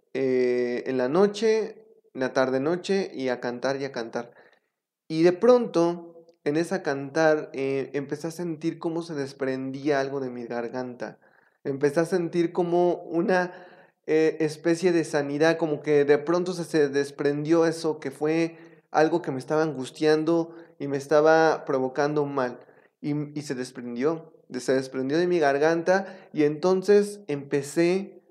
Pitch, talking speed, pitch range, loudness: 155 Hz, 150 wpm, 140-170 Hz, -25 LUFS